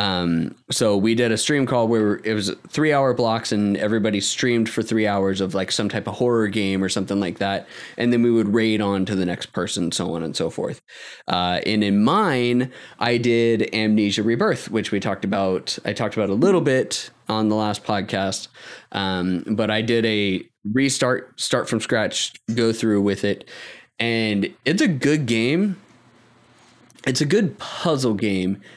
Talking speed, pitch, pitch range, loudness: 190 wpm, 110 Hz, 100-120 Hz, -21 LUFS